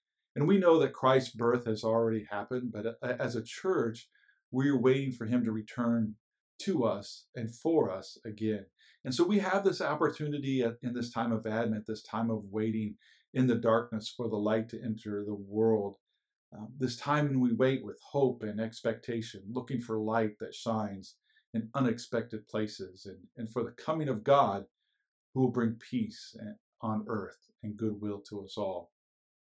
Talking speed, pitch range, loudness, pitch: 170 wpm, 110-130 Hz, -32 LUFS, 115 Hz